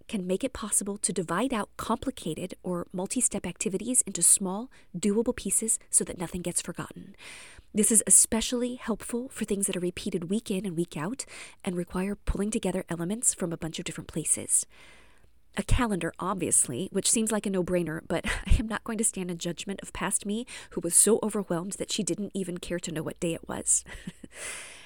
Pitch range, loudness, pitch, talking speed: 175-220 Hz, -27 LUFS, 195 Hz, 200 wpm